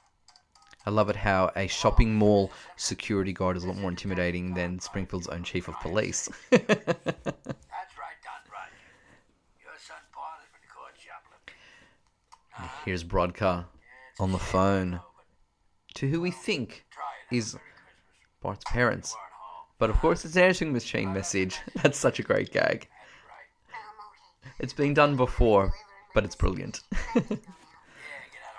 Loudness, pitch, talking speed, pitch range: -28 LUFS, 95 Hz, 110 wpm, 90-120 Hz